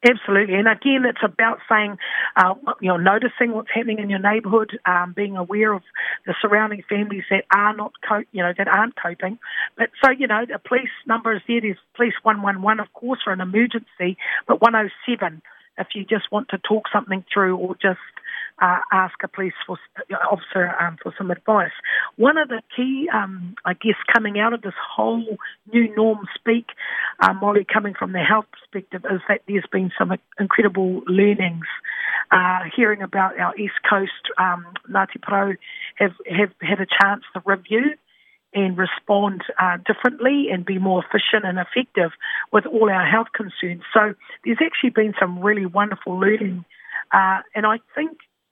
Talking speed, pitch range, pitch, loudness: 175 wpm, 190-225 Hz, 205 Hz, -20 LUFS